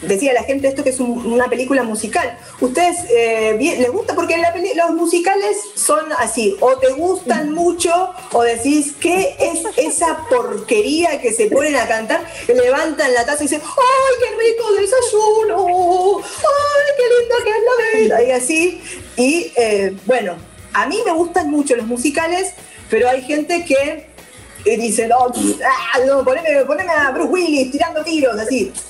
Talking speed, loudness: 170 wpm, -16 LUFS